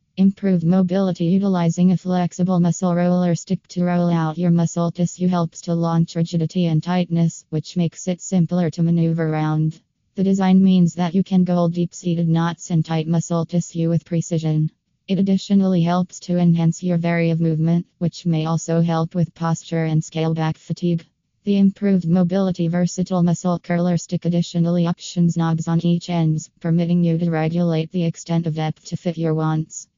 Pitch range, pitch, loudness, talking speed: 165-180 Hz, 170 Hz, -20 LUFS, 170 wpm